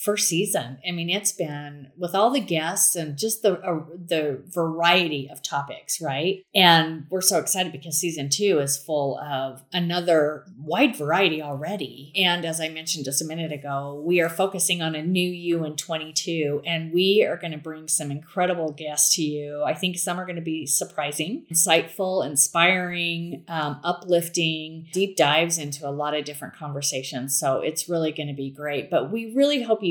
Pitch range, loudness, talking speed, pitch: 150-180 Hz, -23 LUFS, 185 wpm, 165 Hz